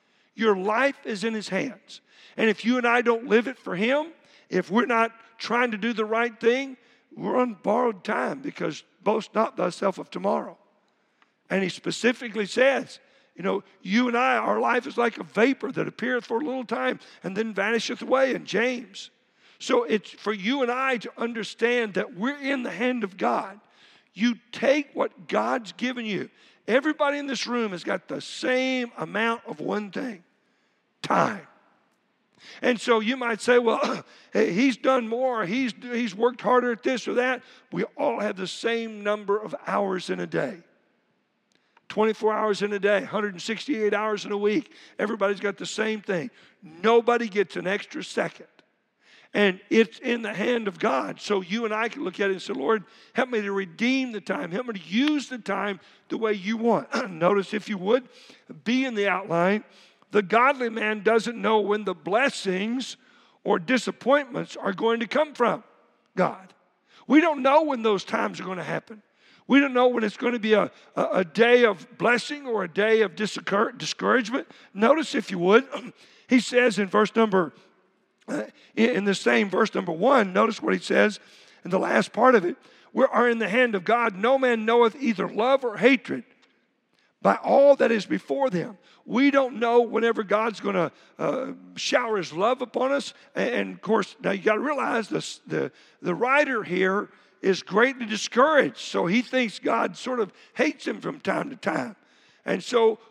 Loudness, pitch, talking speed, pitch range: -25 LUFS, 230 Hz, 185 wpm, 205-250 Hz